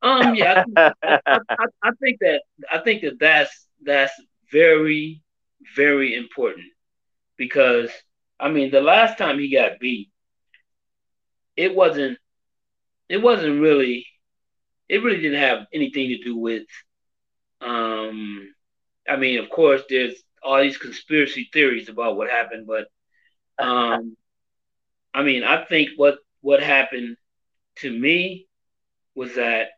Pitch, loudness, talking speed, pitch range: 135 Hz, -19 LUFS, 130 wpm, 115-150 Hz